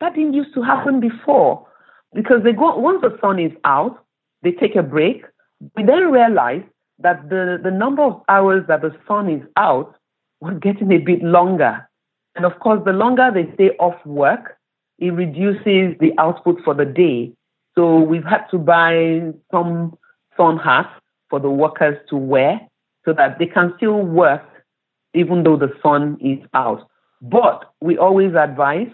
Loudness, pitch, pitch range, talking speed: -16 LUFS, 175 Hz, 160-205 Hz, 170 wpm